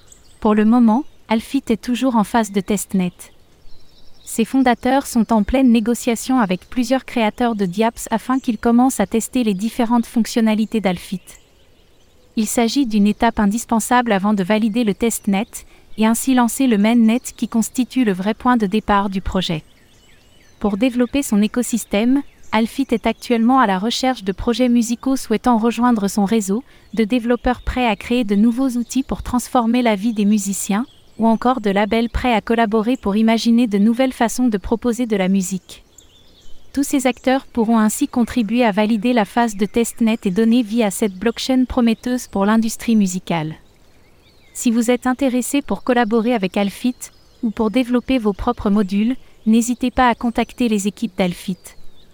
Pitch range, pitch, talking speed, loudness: 210-245 Hz, 230 Hz, 165 wpm, -18 LUFS